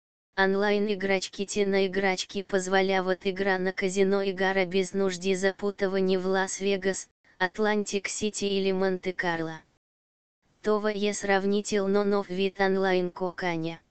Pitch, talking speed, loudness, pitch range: 195 Hz, 110 wpm, -27 LUFS, 185-200 Hz